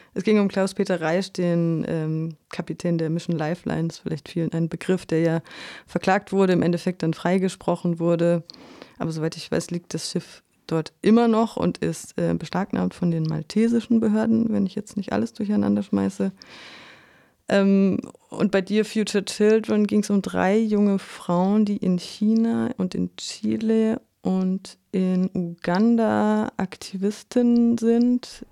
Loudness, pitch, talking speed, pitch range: -23 LUFS, 190 Hz, 150 wpm, 165-215 Hz